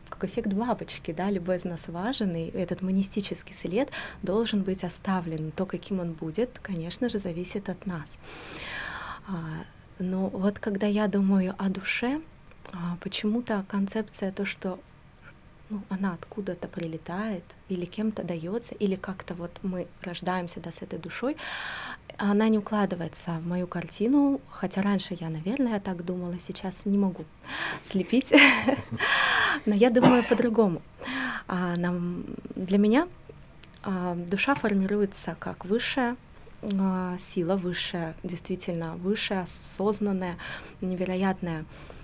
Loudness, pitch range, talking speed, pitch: -28 LUFS, 180-210 Hz, 120 wpm, 190 Hz